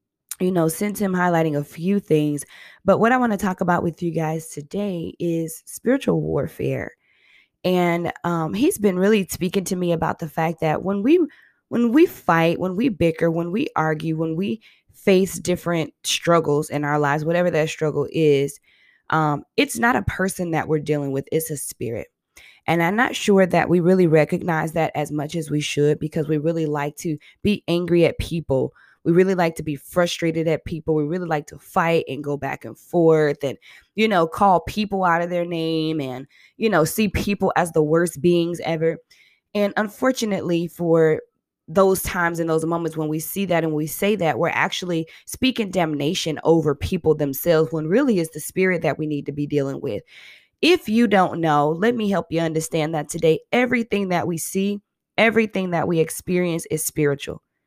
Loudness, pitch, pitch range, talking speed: -21 LUFS, 165 Hz, 155-190 Hz, 195 wpm